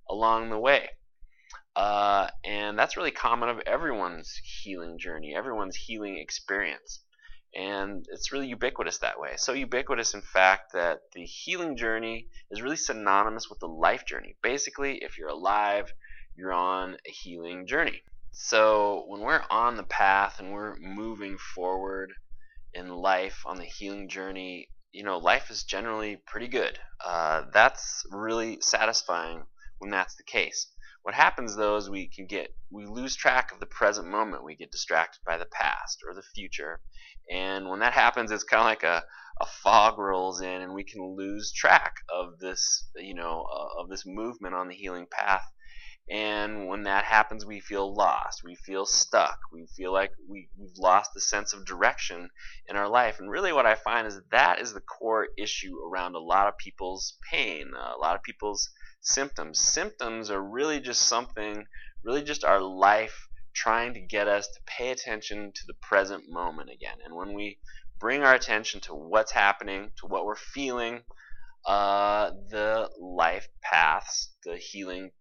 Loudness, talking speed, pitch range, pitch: -27 LUFS, 170 wpm, 95-110 Hz, 100 Hz